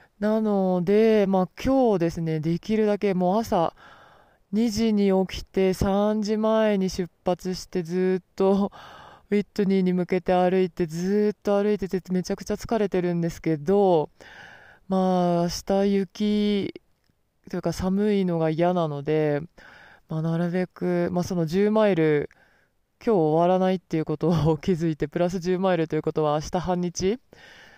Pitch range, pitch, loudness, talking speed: 170-205 Hz, 185 Hz, -24 LUFS, 285 characters per minute